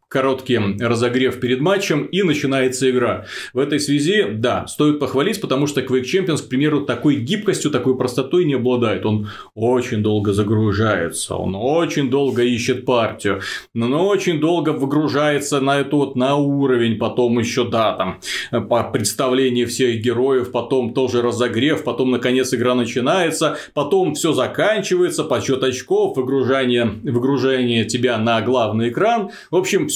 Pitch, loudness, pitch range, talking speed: 130 Hz, -18 LUFS, 120-145 Hz, 140 wpm